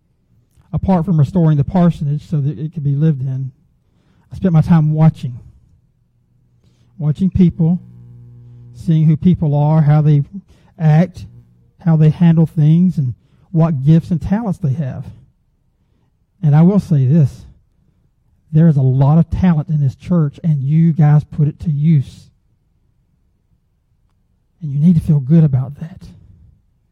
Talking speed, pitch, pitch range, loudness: 145 wpm, 155 Hz, 135-165 Hz, -14 LUFS